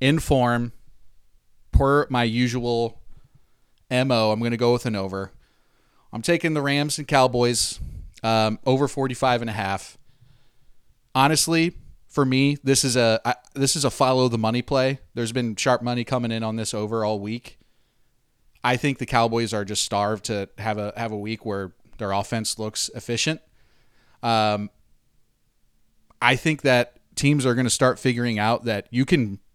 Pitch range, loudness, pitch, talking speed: 110-130 Hz, -23 LUFS, 120 Hz, 165 wpm